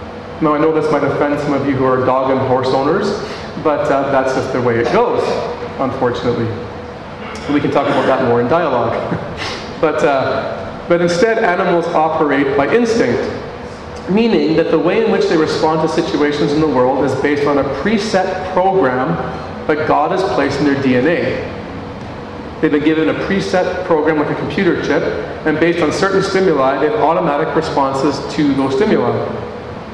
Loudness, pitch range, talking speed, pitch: -15 LUFS, 135-165 Hz, 175 wpm, 145 Hz